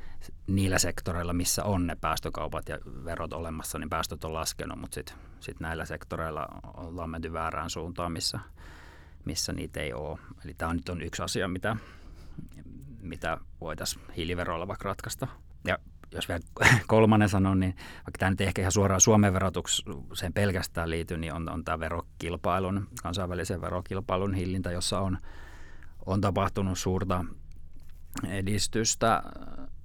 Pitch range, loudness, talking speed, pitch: 80-95 Hz, -30 LUFS, 140 wpm, 85 Hz